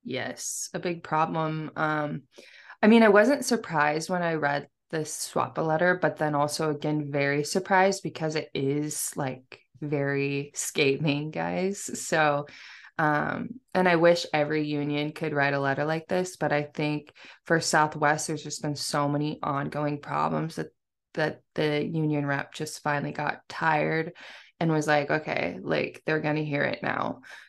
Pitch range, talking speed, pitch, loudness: 145-165 Hz, 160 wpm, 150 Hz, -27 LUFS